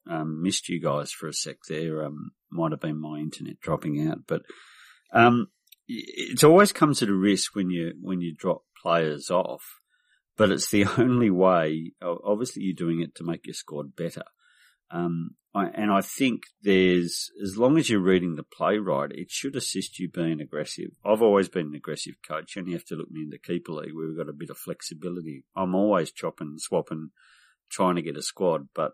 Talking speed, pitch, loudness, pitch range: 200 wpm, 85 Hz, -26 LUFS, 80-100 Hz